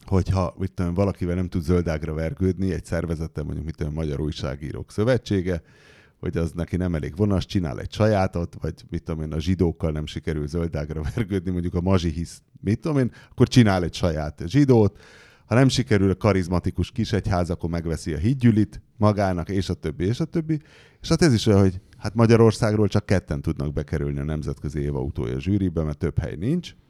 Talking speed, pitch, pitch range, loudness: 195 wpm, 90 Hz, 80-105 Hz, -24 LUFS